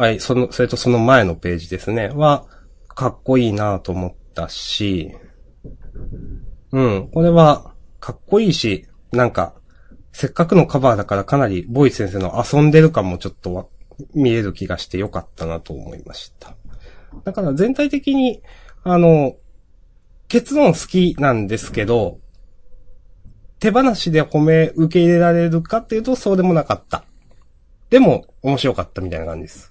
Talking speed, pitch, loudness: 305 characters per minute, 120 Hz, -17 LUFS